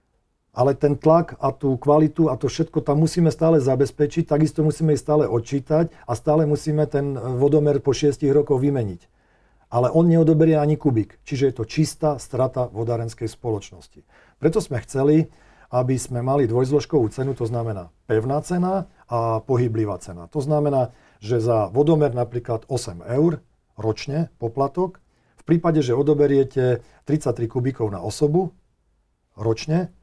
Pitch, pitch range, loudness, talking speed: 140 Hz, 120-155 Hz, -21 LUFS, 145 wpm